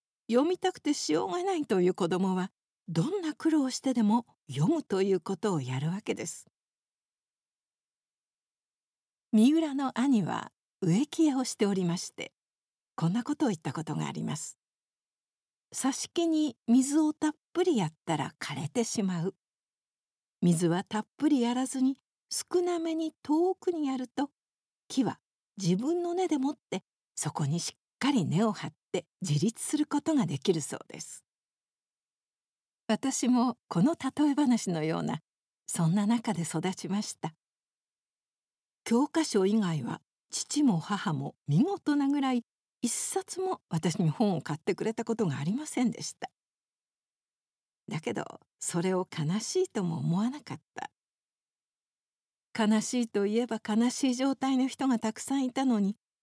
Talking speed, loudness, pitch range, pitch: 265 characters per minute, -30 LUFS, 185-280 Hz, 230 Hz